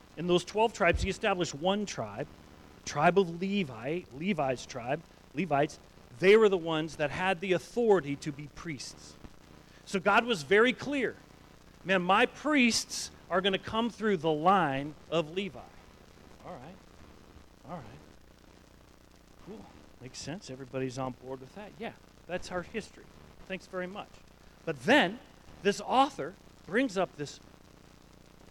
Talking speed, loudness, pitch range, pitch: 145 wpm, -30 LUFS, 145-200 Hz, 185 Hz